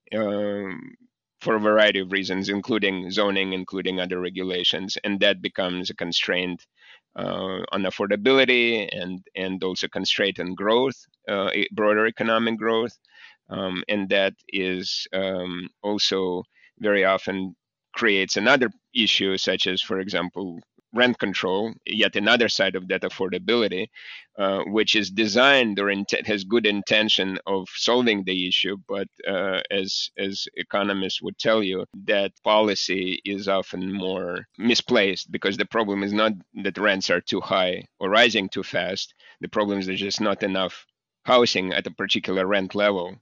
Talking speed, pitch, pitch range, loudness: 150 wpm, 100 Hz, 95-105 Hz, -23 LUFS